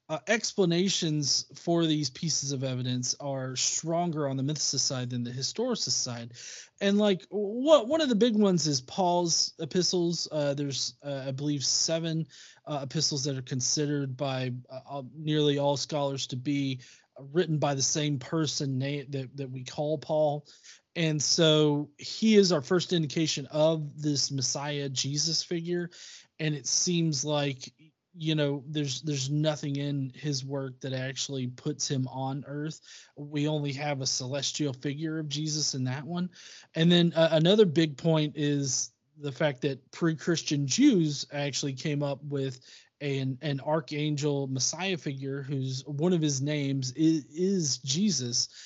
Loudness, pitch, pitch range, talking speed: -28 LUFS, 145 Hz, 135-160 Hz, 155 wpm